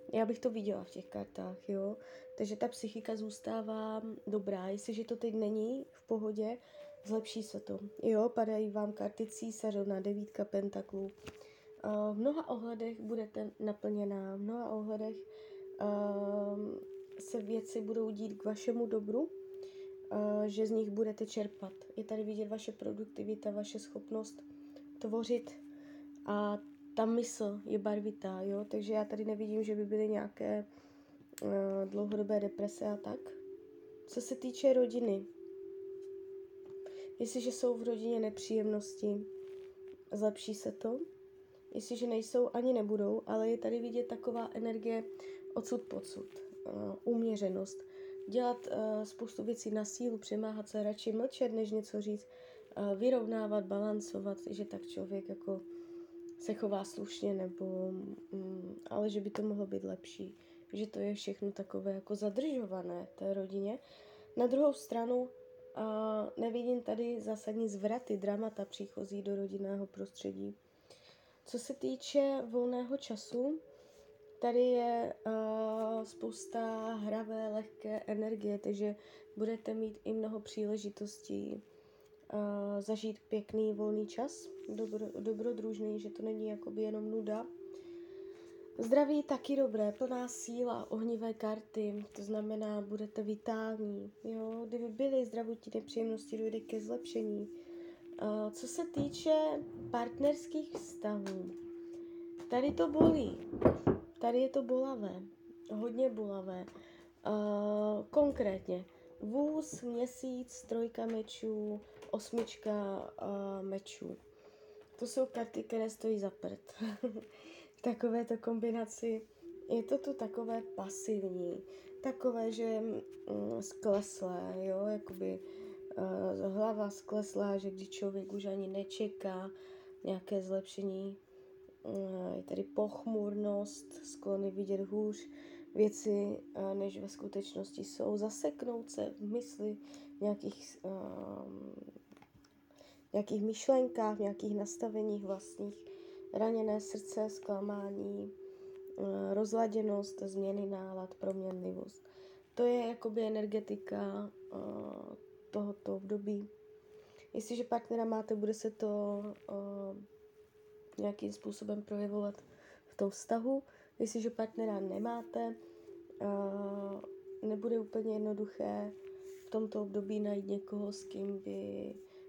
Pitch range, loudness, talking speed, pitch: 200-250 Hz, -38 LUFS, 115 wpm, 215 Hz